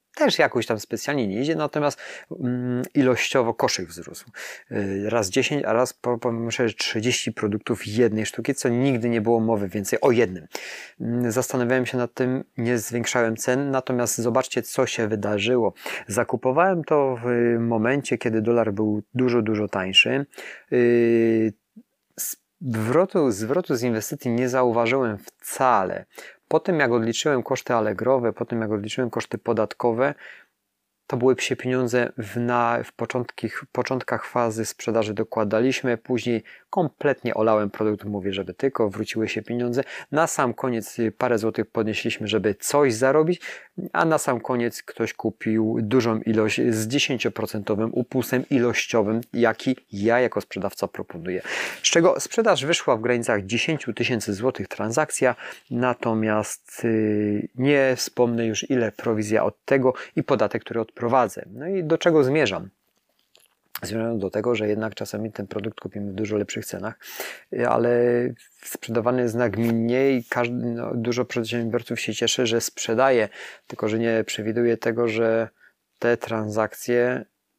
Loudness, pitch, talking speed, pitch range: -23 LUFS, 120 Hz, 135 wpm, 110-125 Hz